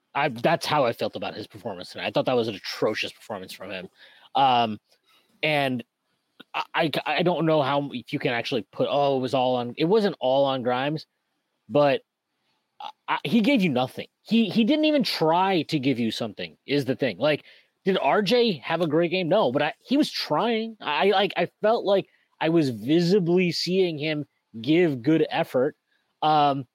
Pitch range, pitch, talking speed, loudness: 140-190 Hz, 155 Hz, 190 wpm, -24 LUFS